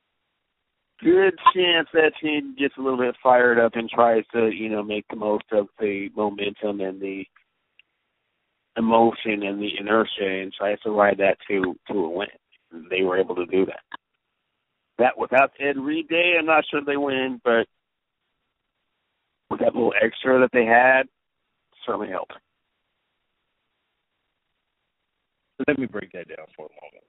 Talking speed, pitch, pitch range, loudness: 160 wpm, 115 Hz, 105-140 Hz, -22 LUFS